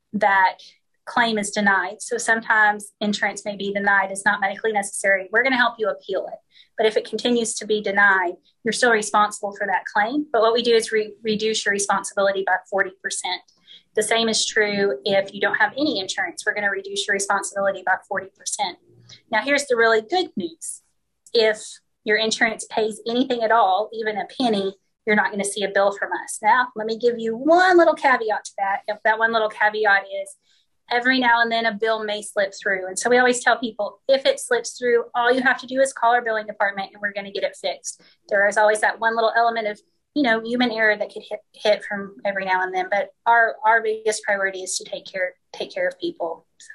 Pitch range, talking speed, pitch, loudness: 200-235 Hz, 225 wpm, 215 Hz, -21 LUFS